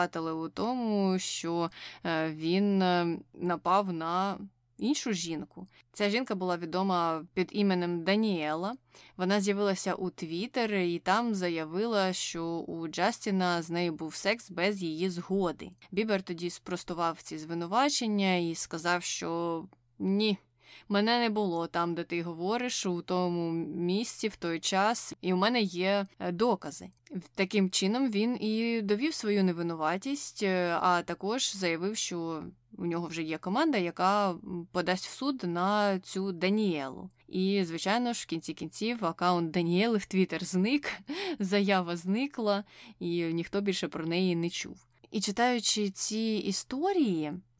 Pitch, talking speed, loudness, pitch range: 185 Hz, 135 wpm, -31 LUFS, 170-205 Hz